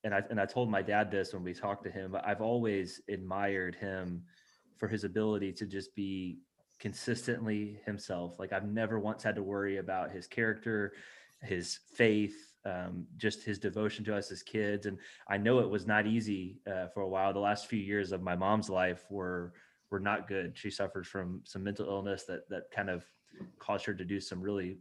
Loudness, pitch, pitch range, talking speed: -36 LUFS, 100 Hz, 95-105 Hz, 205 wpm